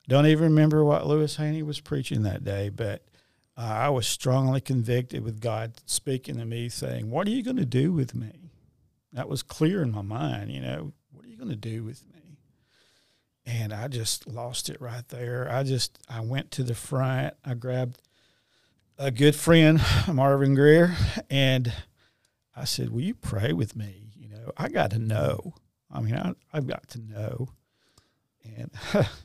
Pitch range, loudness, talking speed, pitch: 115-145 Hz, -26 LUFS, 185 wpm, 125 Hz